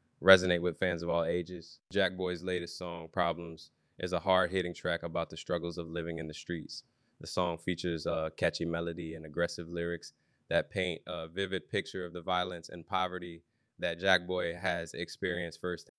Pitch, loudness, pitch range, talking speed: 85 Hz, -33 LUFS, 85-90 Hz, 185 wpm